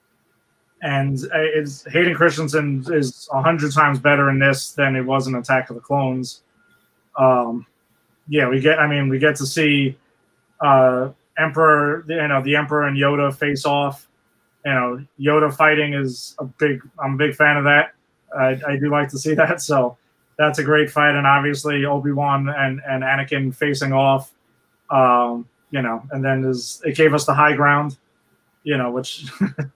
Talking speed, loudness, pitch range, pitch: 170 wpm, -18 LUFS, 135-150 Hz, 140 Hz